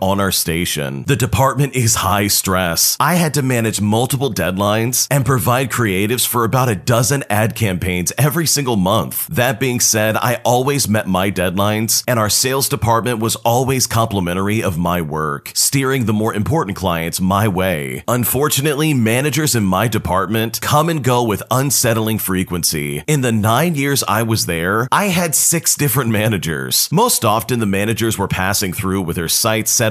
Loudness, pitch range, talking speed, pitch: -16 LUFS, 95-130 Hz, 170 wpm, 110 Hz